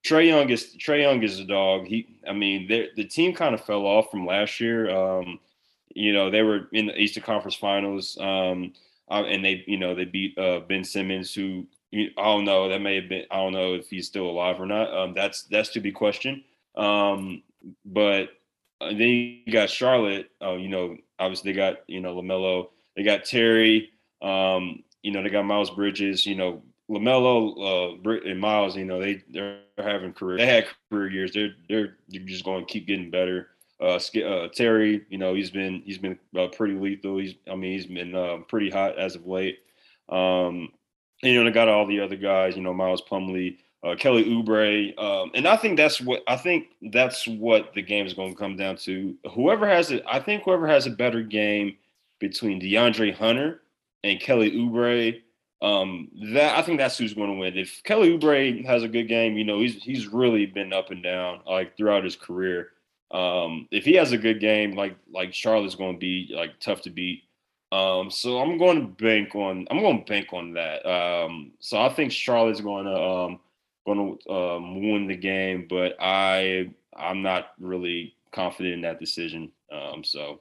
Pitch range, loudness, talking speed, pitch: 95-110 Hz, -24 LUFS, 200 wpm, 100 Hz